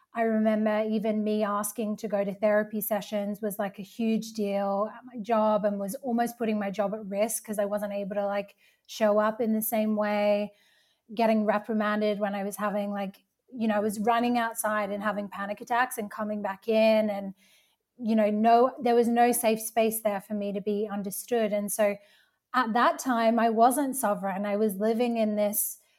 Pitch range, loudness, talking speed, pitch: 205-225 Hz, -27 LUFS, 200 wpm, 215 Hz